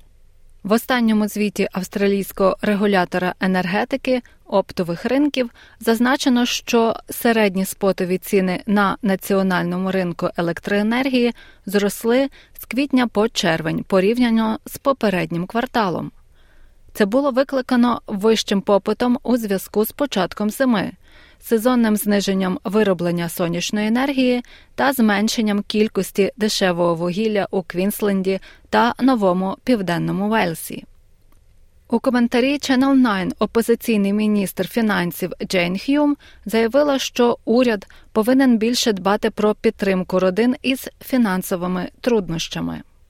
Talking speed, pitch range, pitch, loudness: 100 wpm, 185-240 Hz, 210 Hz, -19 LUFS